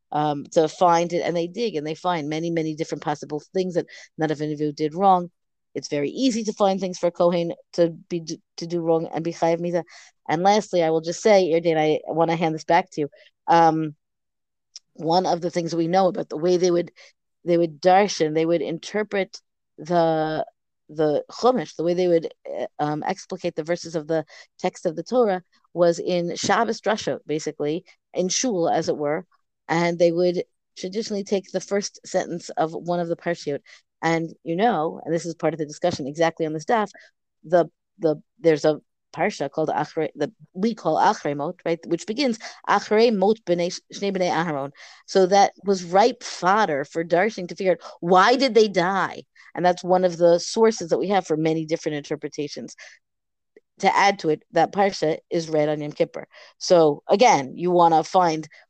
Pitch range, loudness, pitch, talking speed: 160-185 Hz, -22 LUFS, 170 Hz, 195 wpm